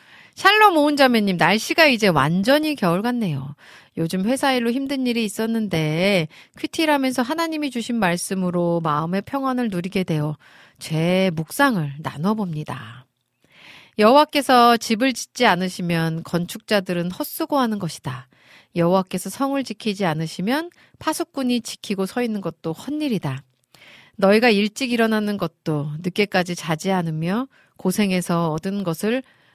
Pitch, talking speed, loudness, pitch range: 195 Hz, 310 characters per minute, -20 LUFS, 165-245 Hz